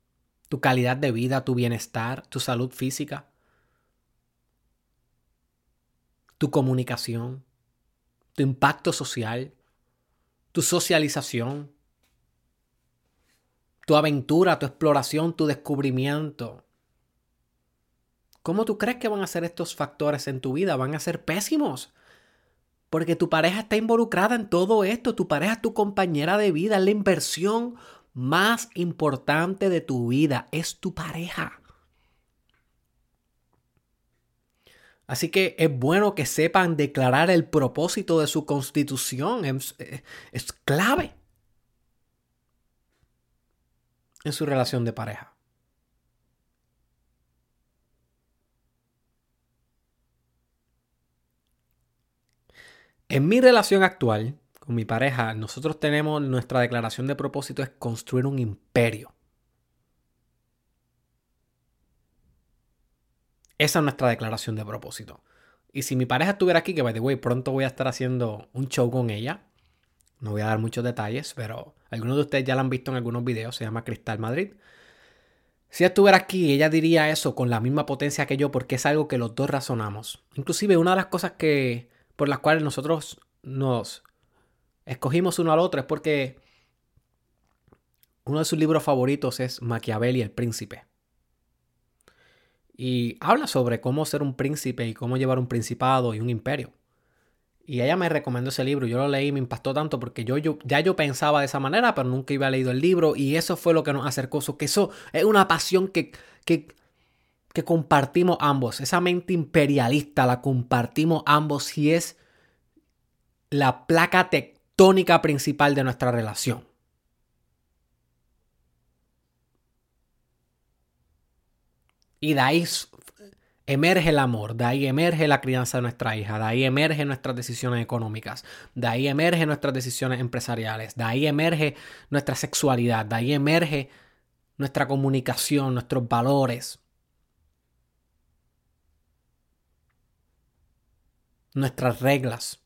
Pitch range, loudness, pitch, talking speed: 115-155 Hz, -24 LUFS, 135 Hz, 130 wpm